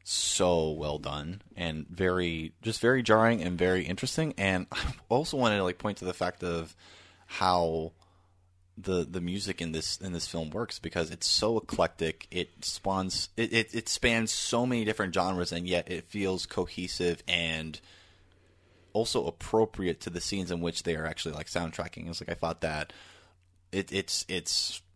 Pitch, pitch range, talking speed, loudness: 90 Hz, 85-95 Hz, 175 wpm, -30 LUFS